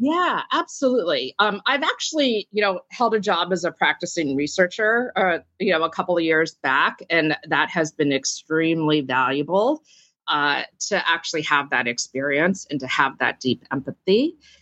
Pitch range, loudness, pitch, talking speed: 155-215 Hz, -21 LUFS, 175 Hz, 165 wpm